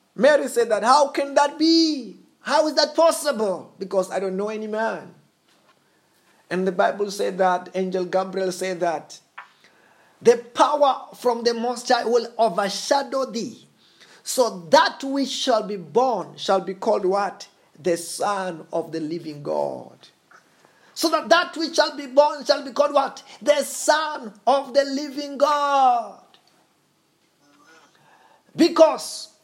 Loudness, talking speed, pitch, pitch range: -21 LUFS, 140 wpm, 245 Hz, 195-290 Hz